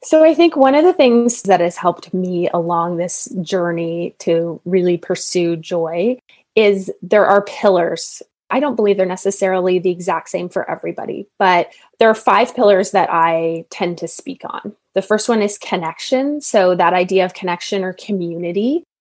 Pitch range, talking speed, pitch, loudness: 175-215 Hz, 175 wpm, 185 Hz, -16 LUFS